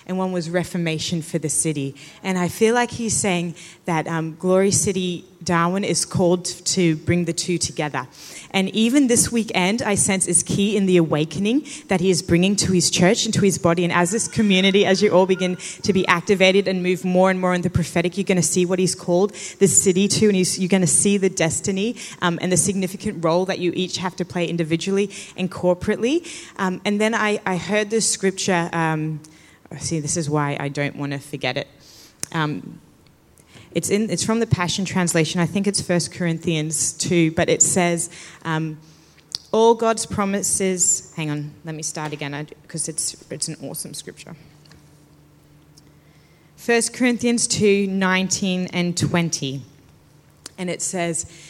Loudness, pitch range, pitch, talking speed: -20 LUFS, 165-195 Hz, 180 Hz, 185 wpm